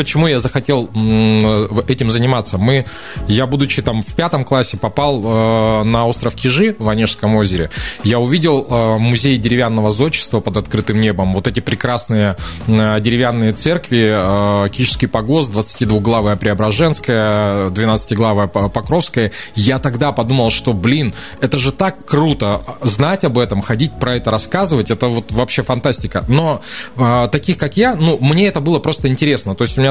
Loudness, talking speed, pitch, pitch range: -15 LUFS, 155 wpm, 120 Hz, 110-140 Hz